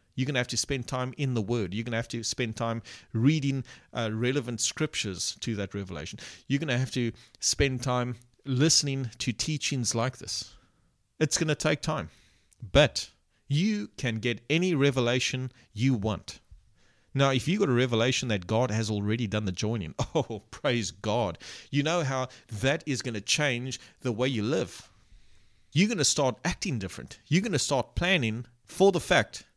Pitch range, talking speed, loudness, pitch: 110-135 Hz, 185 wpm, -28 LUFS, 120 Hz